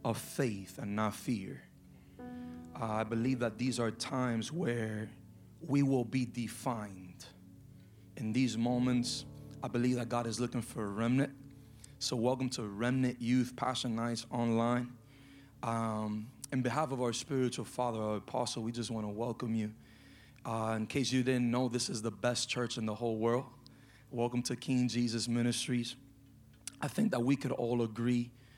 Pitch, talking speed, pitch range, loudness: 120 Hz, 170 wpm, 115-130 Hz, -35 LUFS